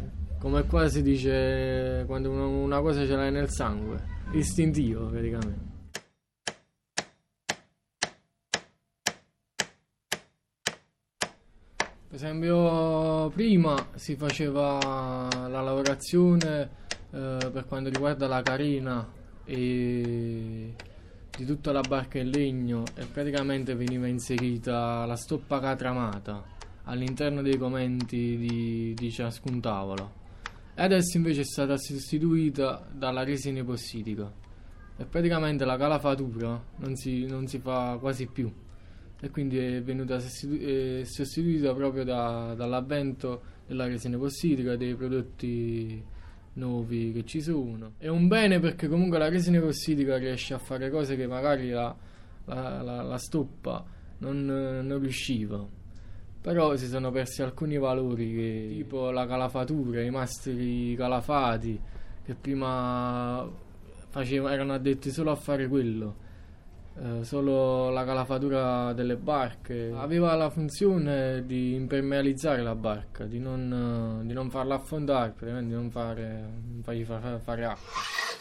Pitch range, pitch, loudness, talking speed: 115-140 Hz, 130 Hz, -30 LUFS, 120 wpm